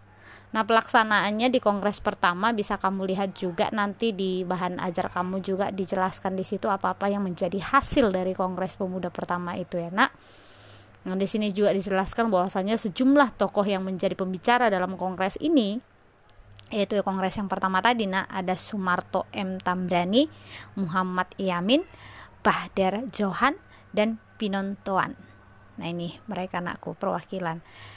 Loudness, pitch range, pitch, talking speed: -26 LUFS, 180-210 Hz, 190 Hz, 140 wpm